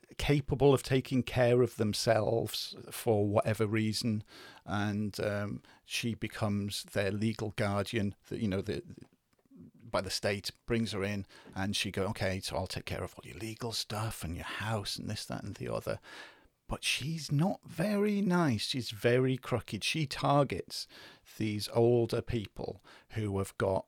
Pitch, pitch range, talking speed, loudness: 110 Hz, 100-125 Hz, 165 wpm, -33 LUFS